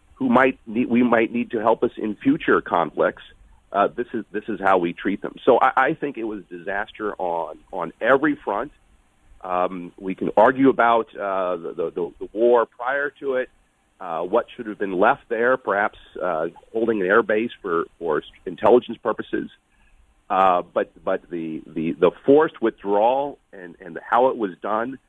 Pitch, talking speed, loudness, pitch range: 115 Hz, 180 wpm, -22 LUFS, 105-135 Hz